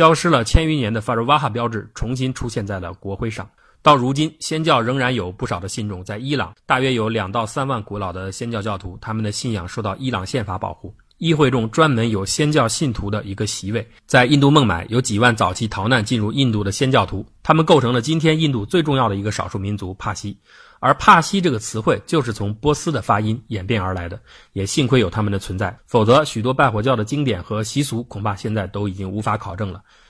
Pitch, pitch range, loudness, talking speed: 115 Hz, 100-135 Hz, -19 LUFS, 350 characters per minute